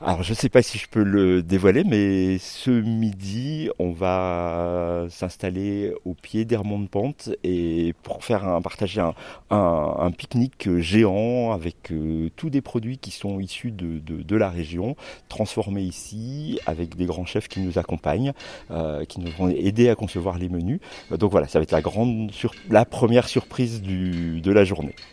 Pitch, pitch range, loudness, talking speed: 95 Hz, 85-110 Hz, -24 LUFS, 185 wpm